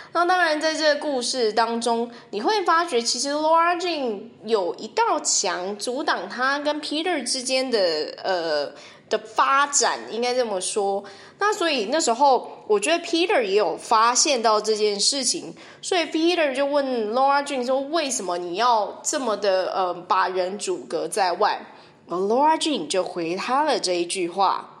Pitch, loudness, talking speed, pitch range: 265 Hz, -22 LUFS, 300 characters per minute, 215-325 Hz